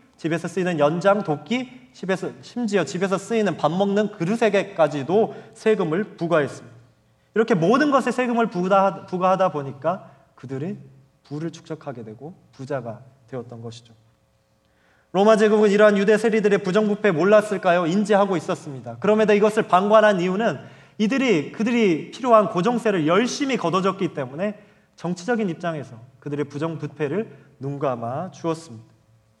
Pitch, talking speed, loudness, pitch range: 180 Hz, 350 characters per minute, -21 LUFS, 145-215 Hz